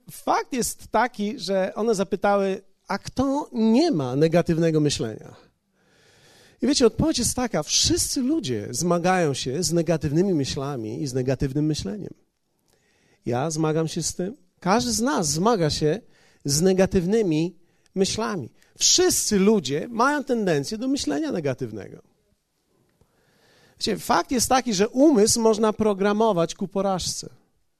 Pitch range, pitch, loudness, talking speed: 160-230 Hz, 195 Hz, -23 LUFS, 125 wpm